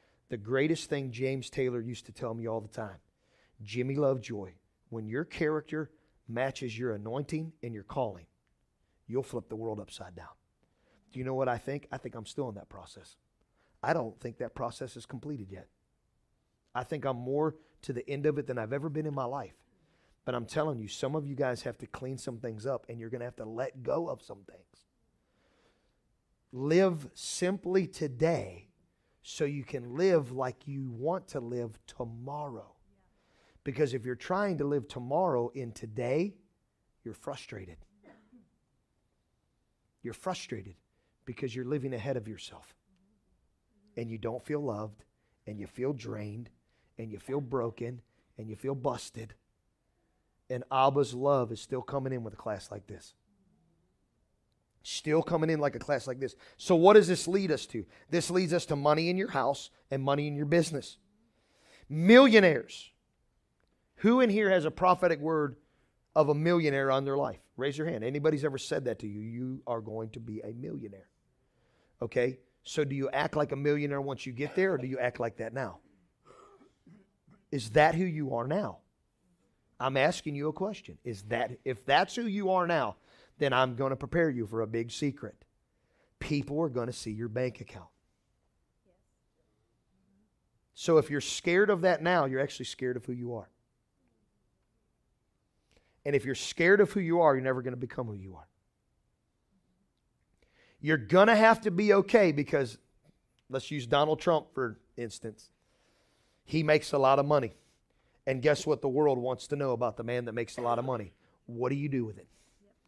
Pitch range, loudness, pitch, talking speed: 115-150 Hz, -31 LUFS, 130 Hz, 180 wpm